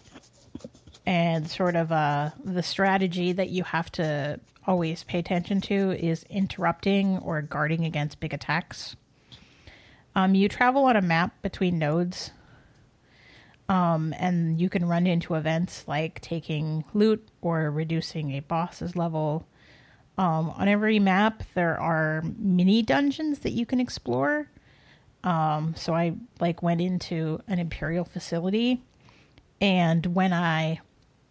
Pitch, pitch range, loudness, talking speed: 170 Hz, 160-190 Hz, -26 LUFS, 130 wpm